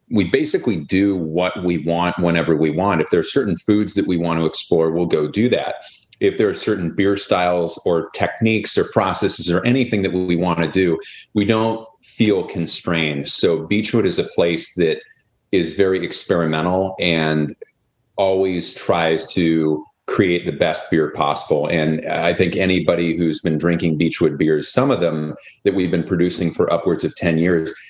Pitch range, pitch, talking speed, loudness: 80-100 Hz, 85 Hz, 180 wpm, -18 LUFS